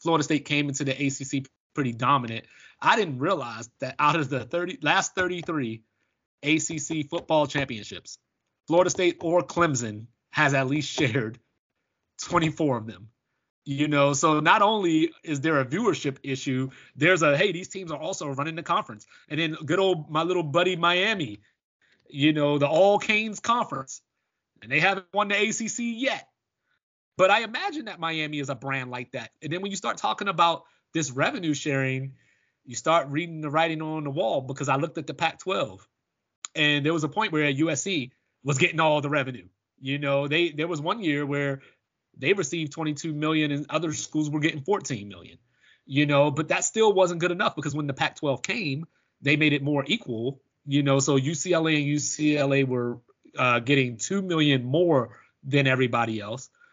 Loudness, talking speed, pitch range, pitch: -25 LUFS, 180 wpm, 135-170 Hz, 150 Hz